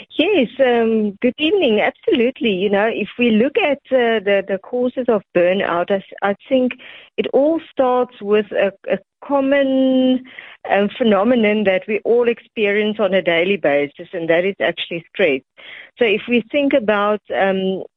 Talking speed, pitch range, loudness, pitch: 160 wpm, 195-255 Hz, -17 LUFS, 215 Hz